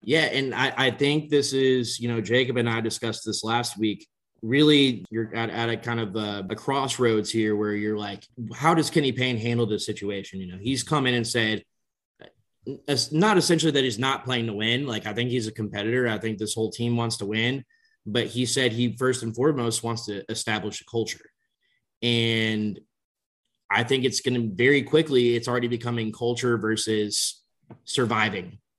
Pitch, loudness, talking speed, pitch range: 120 Hz, -24 LUFS, 190 wpm, 110-130 Hz